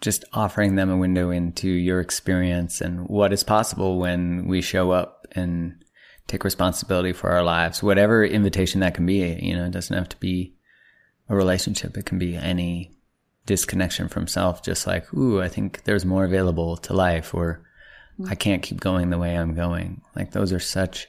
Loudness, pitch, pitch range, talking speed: -23 LUFS, 90 Hz, 90-95 Hz, 190 wpm